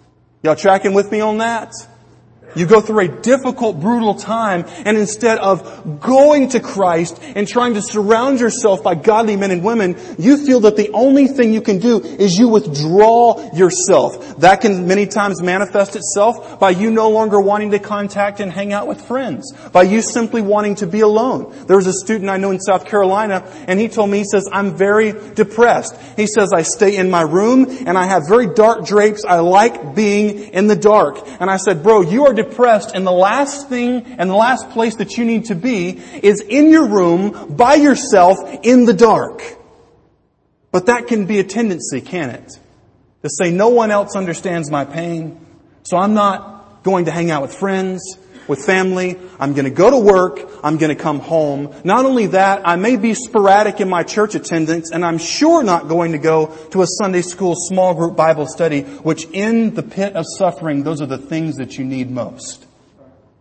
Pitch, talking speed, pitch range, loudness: 200 Hz, 200 wpm, 175-220 Hz, -14 LUFS